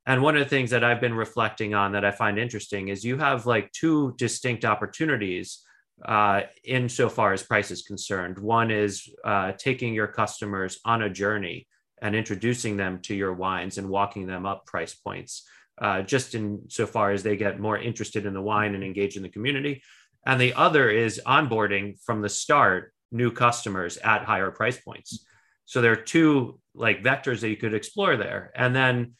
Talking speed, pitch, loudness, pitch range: 195 wpm, 105 Hz, -25 LUFS, 100-120 Hz